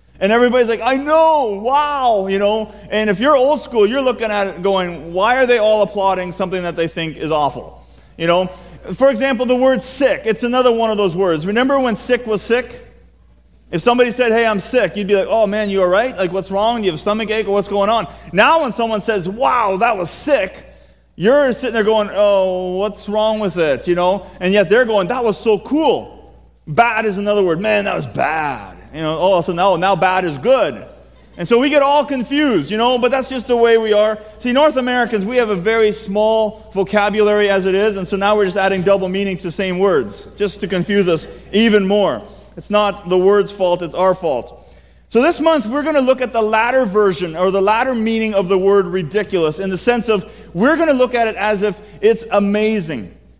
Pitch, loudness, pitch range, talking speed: 210 Hz, -16 LUFS, 195-245 Hz, 230 wpm